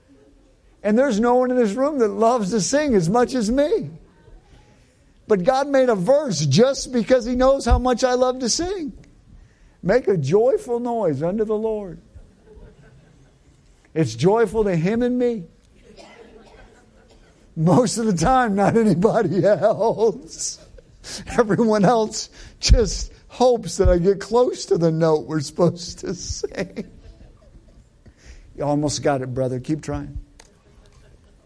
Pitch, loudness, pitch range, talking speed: 225 Hz, -20 LUFS, 175-255 Hz, 135 wpm